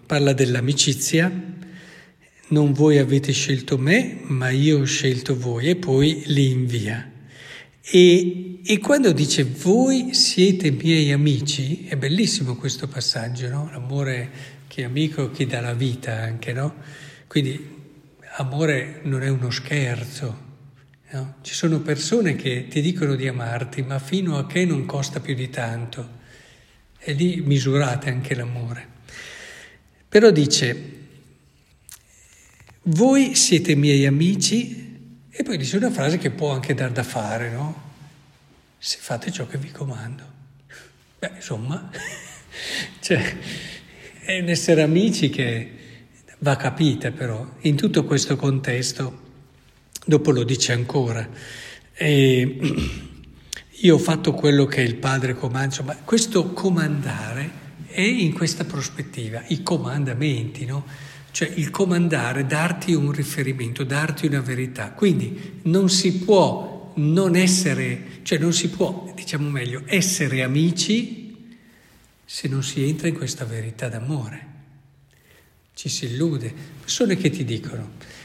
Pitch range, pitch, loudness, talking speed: 130-165 Hz, 145 Hz, -21 LUFS, 130 wpm